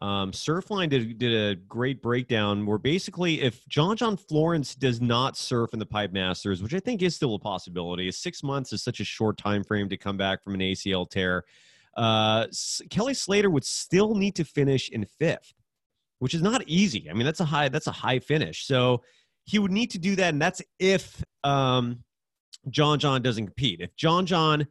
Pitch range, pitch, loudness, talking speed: 105-170 Hz, 130 Hz, -26 LUFS, 205 wpm